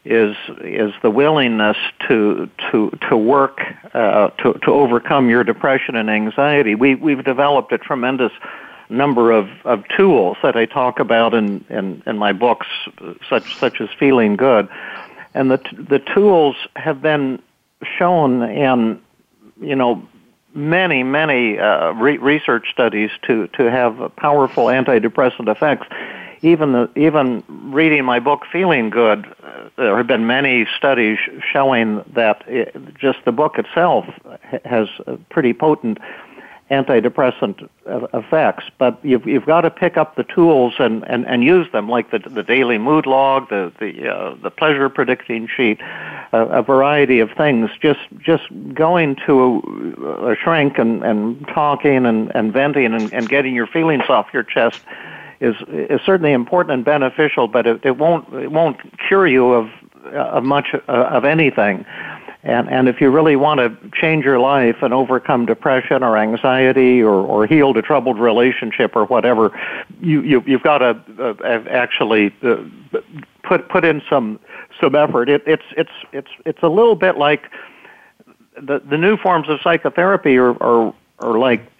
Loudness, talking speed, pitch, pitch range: -16 LUFS, 165 wpm, 135 Hz, 120-155 Hz